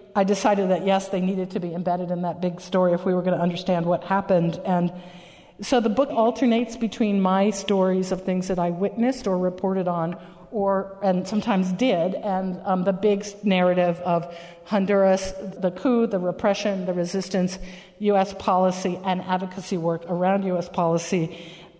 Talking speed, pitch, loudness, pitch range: 170 wpm, 185 Hz, -23 LUFS, 180-200 Hz